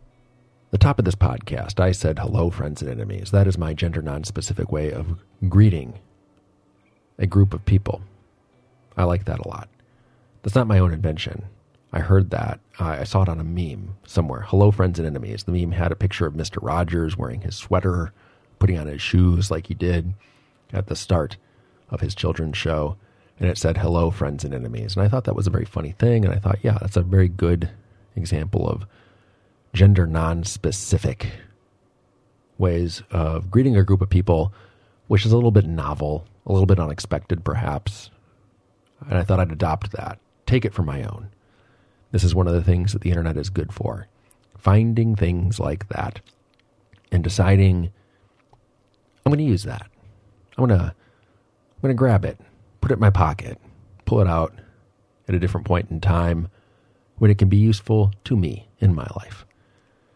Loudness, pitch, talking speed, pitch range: -22 LUFS, 100 Hz, 185 wpm, 90-110 Hz